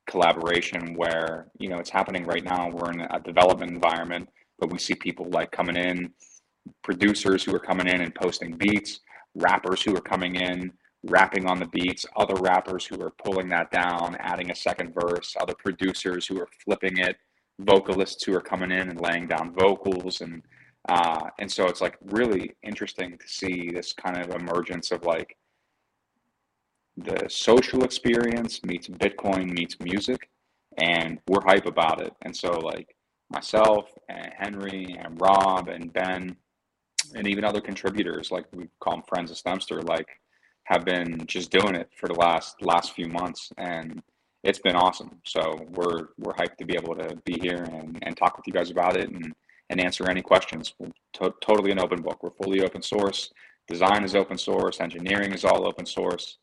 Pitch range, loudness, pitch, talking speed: 85-95 Hz, -26 LUFS, 90 Hz, 180 wpm